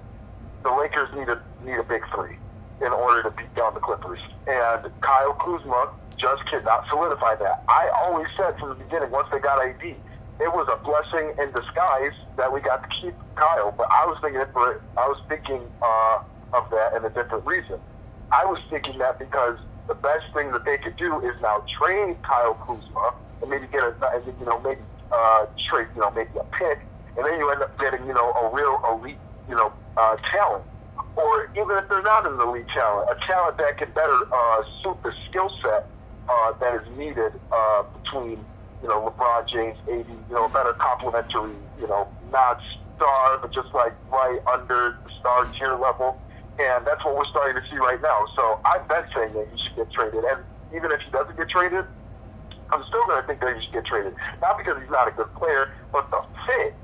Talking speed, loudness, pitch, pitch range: 210 wpm, -23 LUFS, 125 Hz, 110-140 Hz